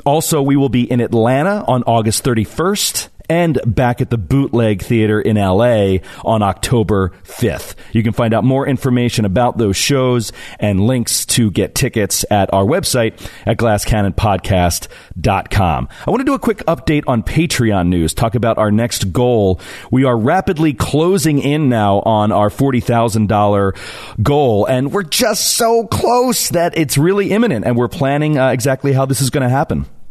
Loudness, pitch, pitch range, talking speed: -14 LUFS, 120 Hz, 105-140 Hz, 165 wpm